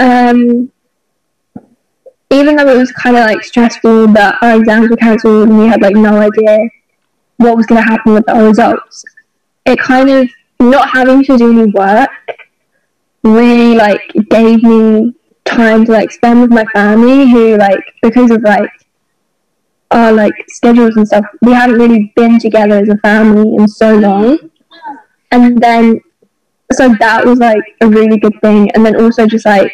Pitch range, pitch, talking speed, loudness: 215-245 Hz, 230 Hz, 170 wpm, -7 LUFS